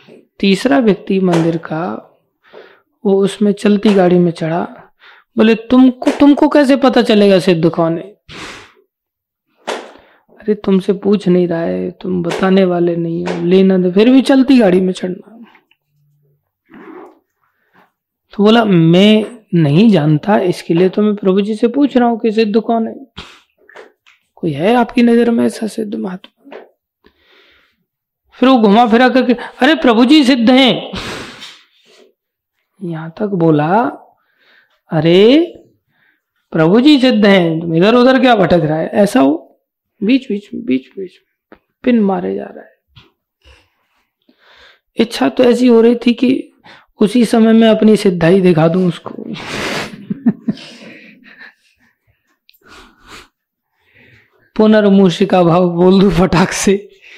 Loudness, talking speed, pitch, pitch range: -12 LUFS, 130 wpm, 210 Hz, 180-240 Hz